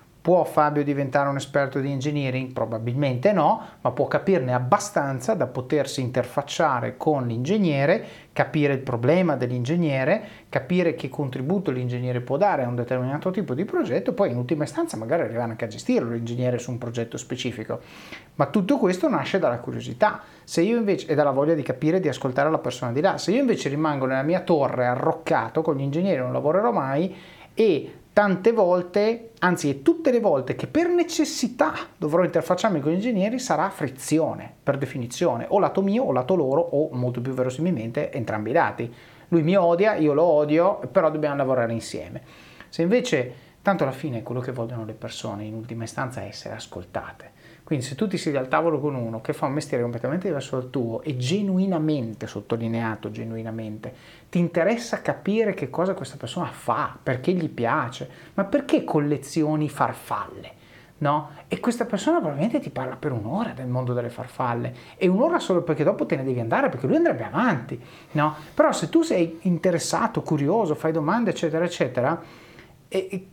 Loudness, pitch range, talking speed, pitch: -24 LUFS, 125-180 Hz, 175 wpm, 150 Hz